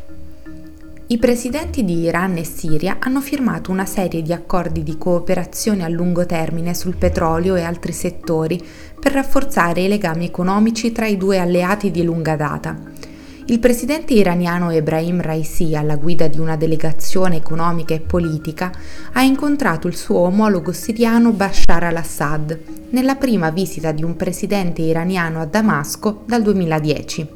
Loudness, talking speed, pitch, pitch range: -18 LUFS, 145 wpm, 175 Hz, 165-210 Hz